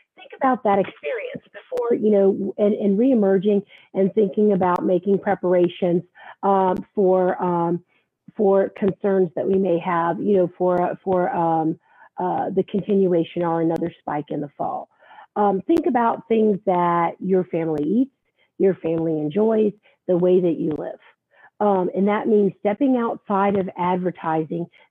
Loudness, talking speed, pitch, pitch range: -21 LUFS, 150 wpm, 190 Hz, 175-205 Hz